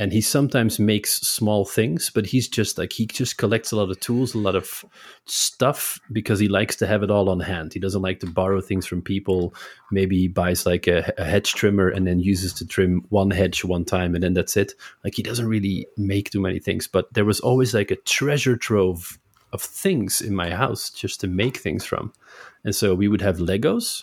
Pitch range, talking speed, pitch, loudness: 95-110 Hz, 225 wpm, 100 Hz, -22 LUFS